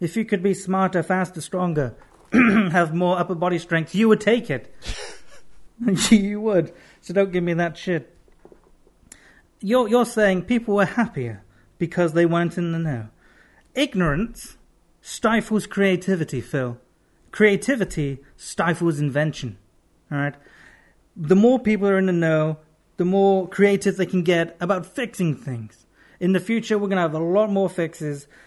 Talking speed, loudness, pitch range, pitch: 150 wpm, -21 LUFS, 160-200 Hz, 180 Hz